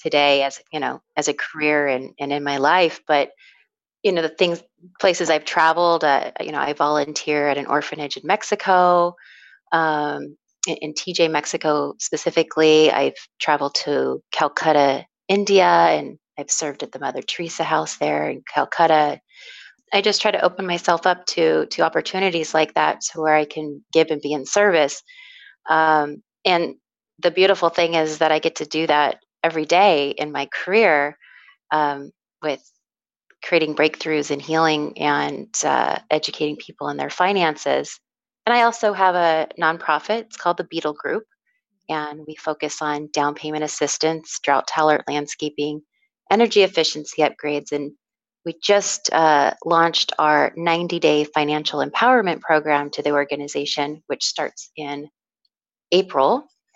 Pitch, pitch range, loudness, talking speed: 160 Hz, 150-180 Hz, -20 LUFS, 155 wpm